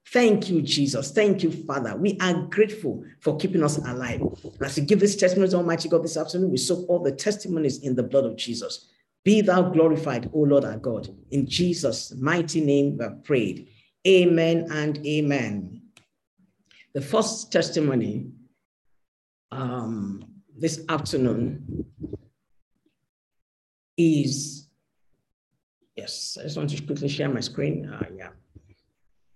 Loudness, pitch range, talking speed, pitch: -24 LUFS, 135-175 Hz, 140 wpm, 150 Hz